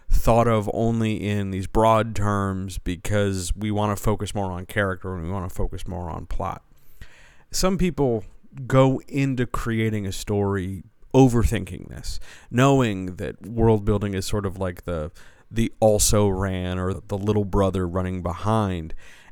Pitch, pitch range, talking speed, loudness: 100 Hz, 95-110 Hz, 155 wpm, -23 LUFS